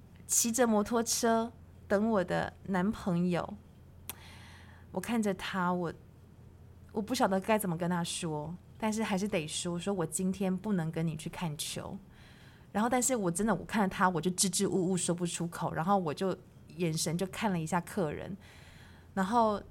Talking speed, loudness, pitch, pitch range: 240 characters per minute, -32 LUFS, 185 Hz, 165-205 Hz